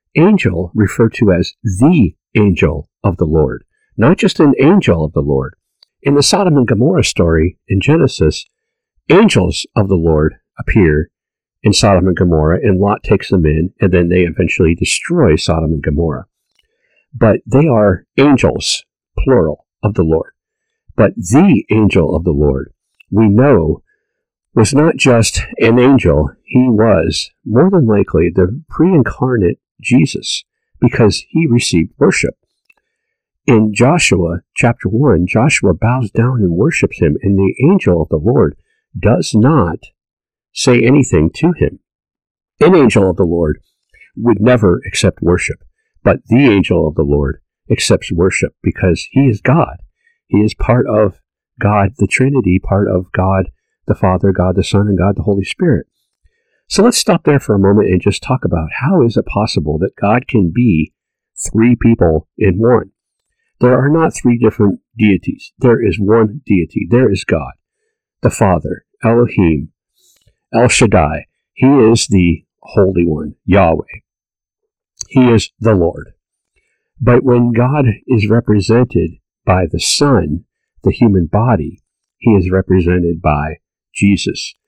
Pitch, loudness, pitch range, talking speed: 105 Hz, -12 LUFS, 90-125 Hz, 150 wpm